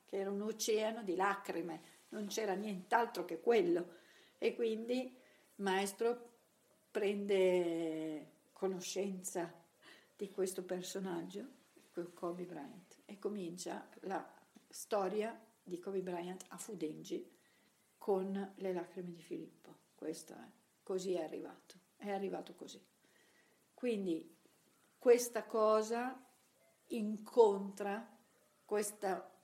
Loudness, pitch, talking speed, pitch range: -39 LUFS, 200 Hz, 100 wpm, 180-225 Hz